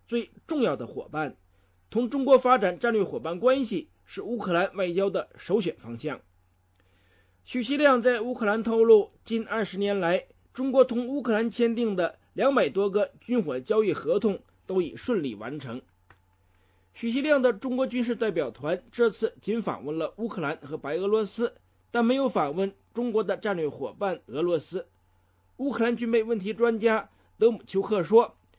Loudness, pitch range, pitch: -27 LUFS, 155-235 Hz, 205 Hz